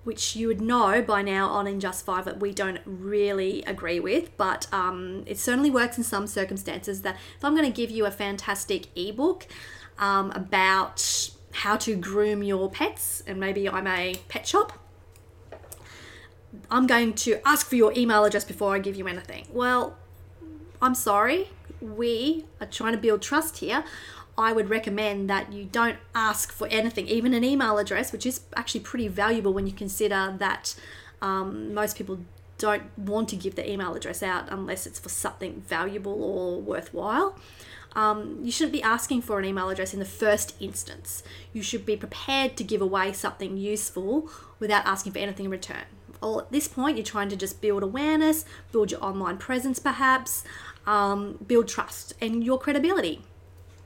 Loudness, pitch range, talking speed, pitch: -26 LUFS, 190-230 Hz, 175 wpm, 205 Hz